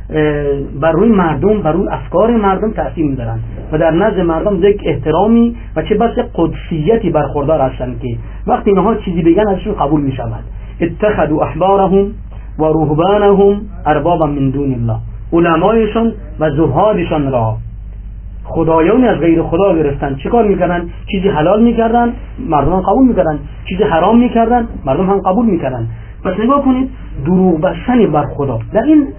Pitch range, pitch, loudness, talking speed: 140-210 Hz, 165 Hz, -13 LUFS, 145 wpm